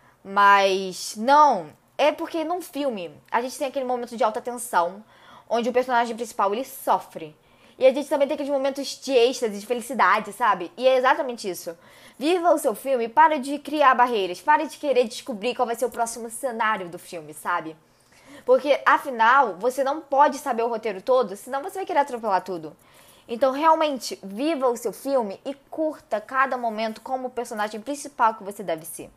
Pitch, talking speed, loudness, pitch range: 250 Hz, 185 wpm, -23 LUFS, 220-280 Hz